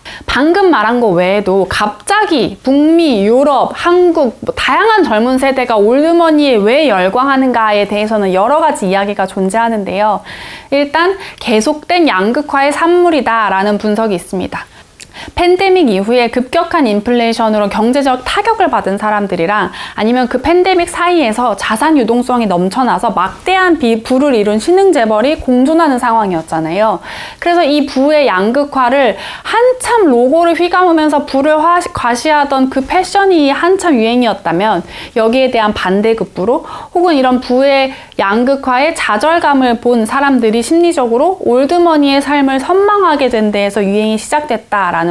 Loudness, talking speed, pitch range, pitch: -11 LUFS, 330 characters per minute, 220-320 Hz, 260 Hz